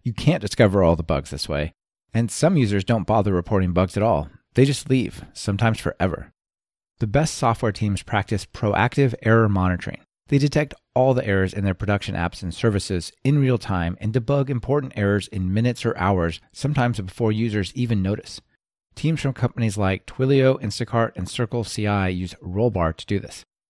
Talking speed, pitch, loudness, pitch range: 175 wpm, 110 Hz, -22 LUFS, 95-125 Hz